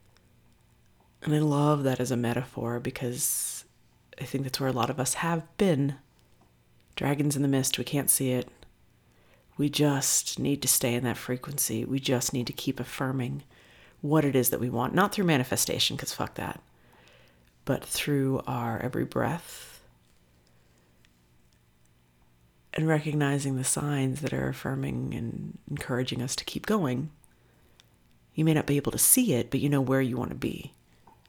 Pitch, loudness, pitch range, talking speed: 125 Hz, -28 LUFS, 85-140 Hz, 165 wpm